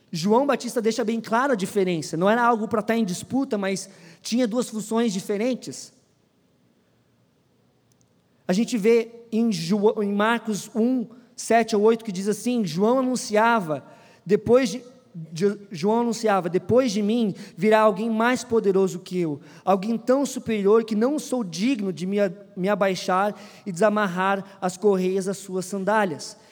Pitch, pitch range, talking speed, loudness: 215 Hz, 195-230 Hz, 145 wpm, -23 LUFS